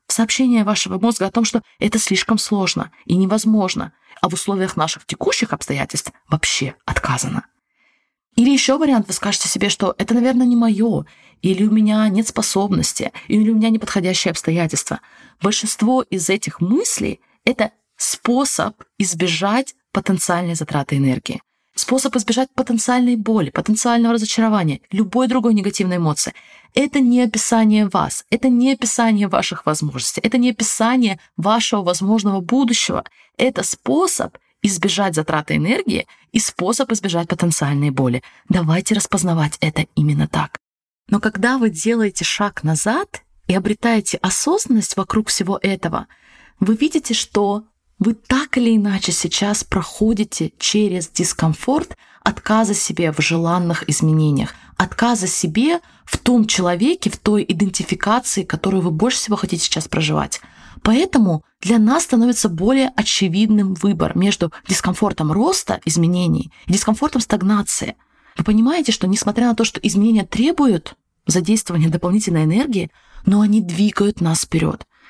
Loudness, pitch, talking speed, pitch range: -18 LUFS, 205 Hz, 130 wpm, 180-230 Hz